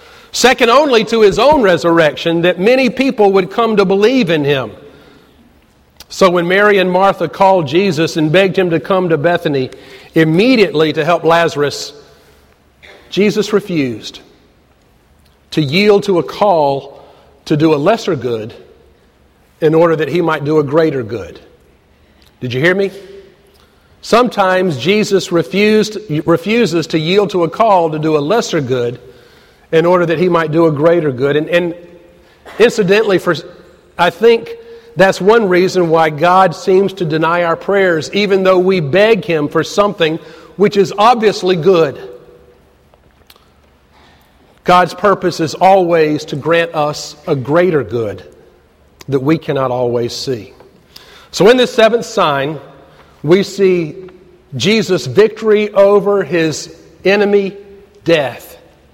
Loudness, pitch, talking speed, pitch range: -12 LUFS, 175 Hz, 140 wpm, 155-195 Hz